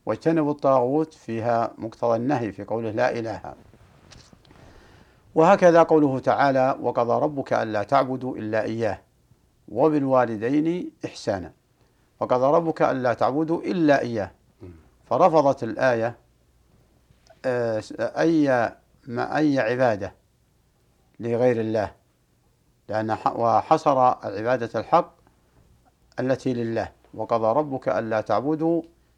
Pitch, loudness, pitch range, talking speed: 120 Hz, -23 LUFS, 110-140 Hz, 90 wpm